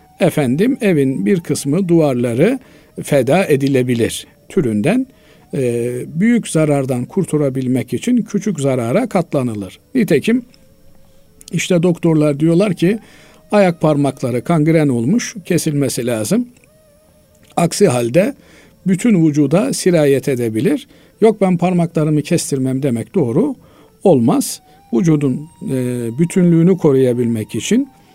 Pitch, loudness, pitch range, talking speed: 155 Hz, -16 LUFS, 130-190 Hz, 90 wpm